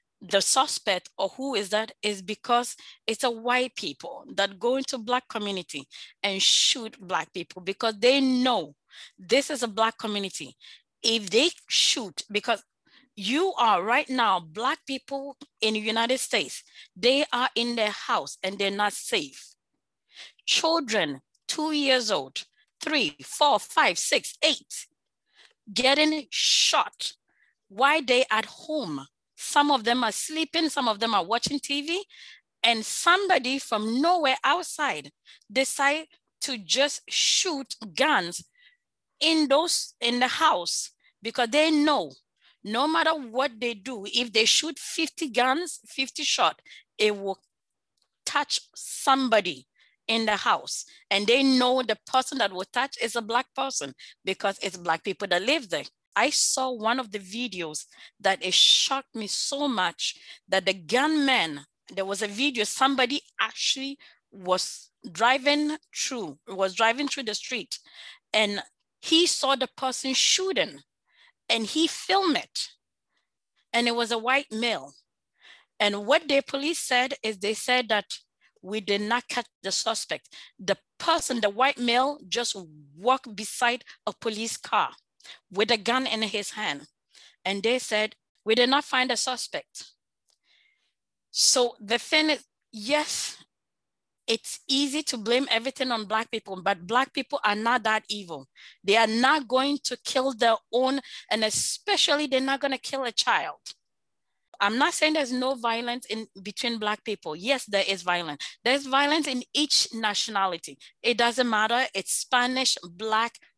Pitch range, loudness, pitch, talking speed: 210-275 Hz, -25 LUFS, 240 Hz, 150 wpm